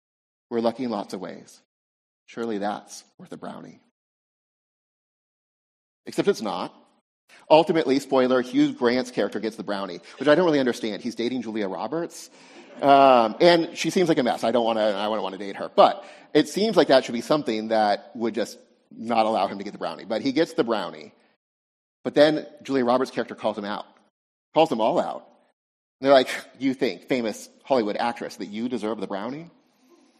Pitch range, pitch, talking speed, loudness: 105-150 Hz, 120 Hz, 190 wpm, -23 LUFS